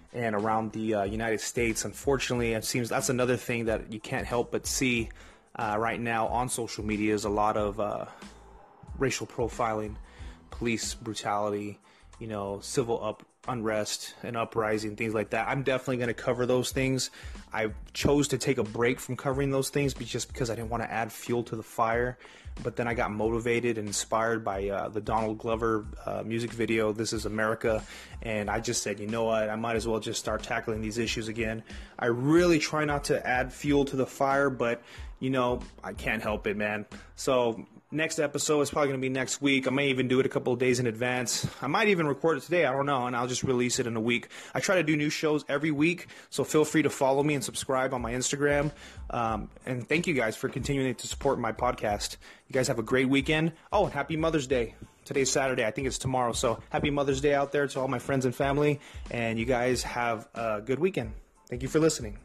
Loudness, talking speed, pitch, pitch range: -29 LUFS, 225 wpm, 120 Hz, 110-135 Hz